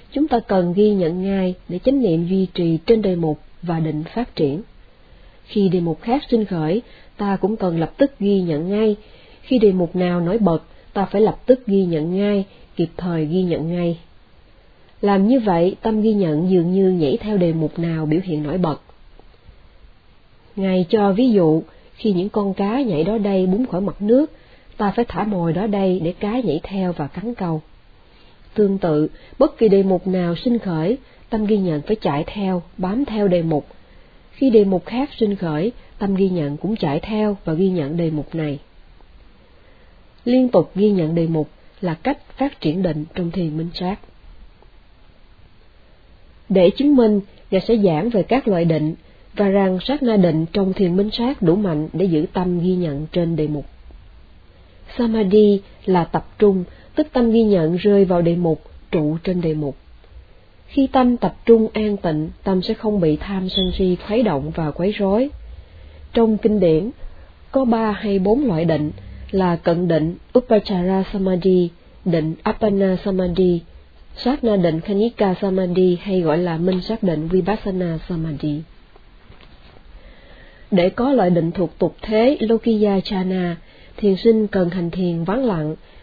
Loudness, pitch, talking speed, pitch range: -19 LUFS, 185 Hz, 180 wpm, 165-210 Hz